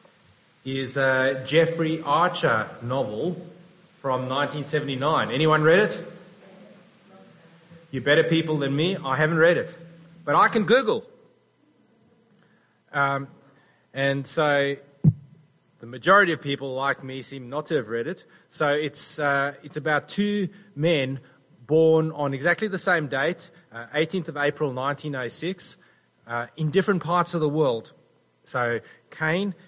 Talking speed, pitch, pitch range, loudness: 130 wpm, 155 Hz, 140-170 Hz, -24 LUFS